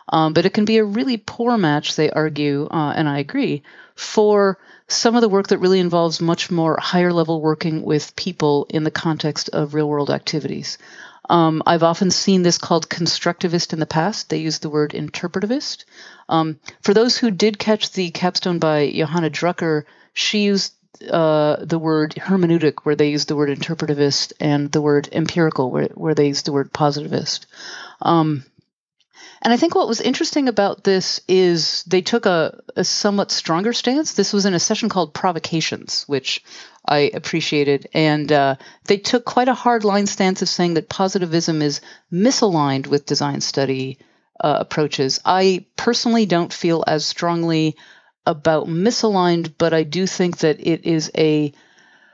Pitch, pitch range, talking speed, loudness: 170 Hz, 155-195 Hz, 170 wpm, -18 LUFS